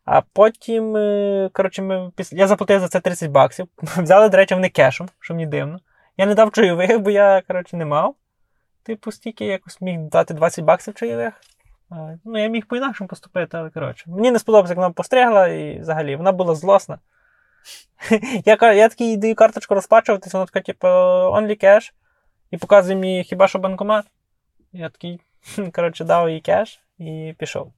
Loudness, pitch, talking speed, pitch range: -17 LUFS, 195 Hz, 165 wpm, 175-220 Hz